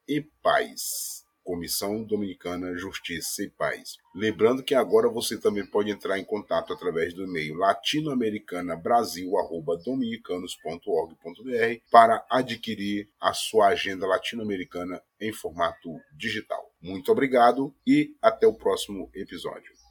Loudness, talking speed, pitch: -26 LUFS, 110 wpm, 115 Hz